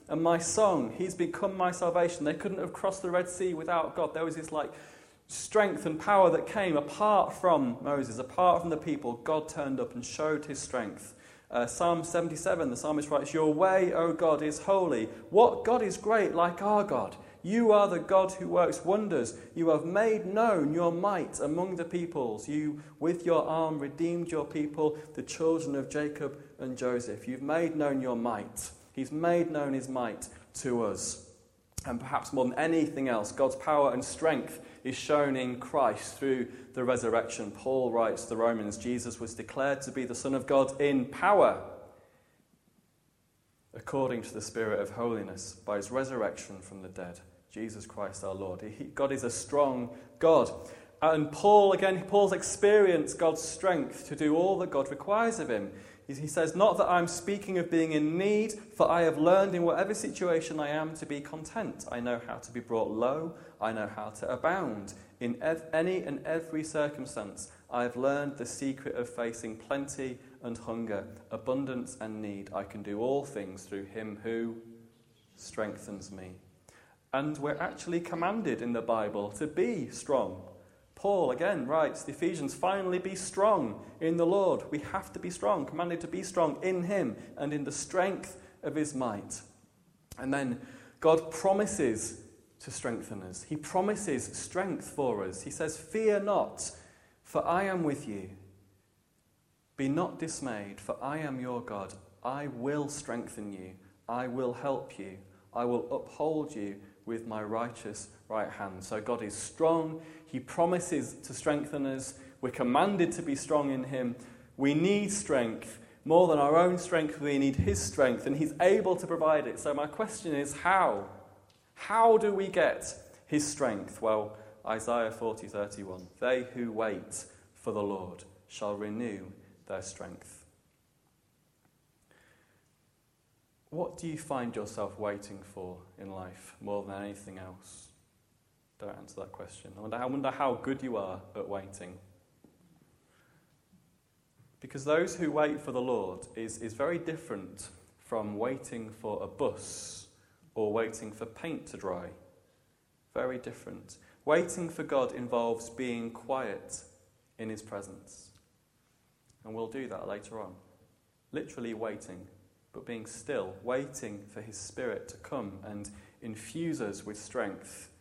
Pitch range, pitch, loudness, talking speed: 110-160 Hz, 135 Hz, -31 LUFS, 165 wpm